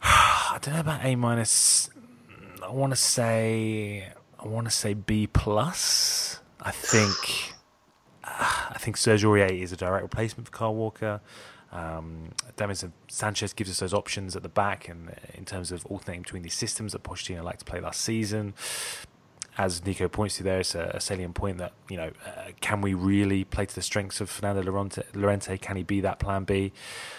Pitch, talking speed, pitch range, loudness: 100 Hz, 190 wpm, 95-110 Hz, -27 LUFS